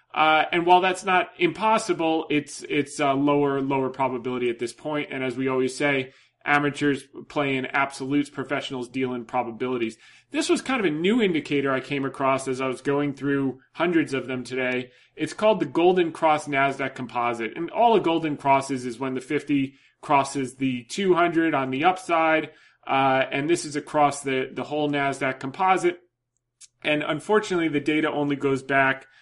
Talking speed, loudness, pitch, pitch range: 175 wpm, -24 LUFS, 140 Hz, 130-160 Hz